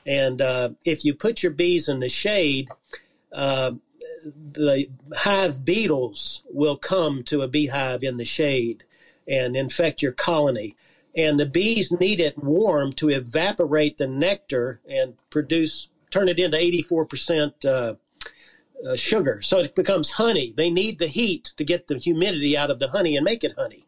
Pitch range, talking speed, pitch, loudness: 140-175 Hz, 165 wpm, 155 Hz, -23 LUFS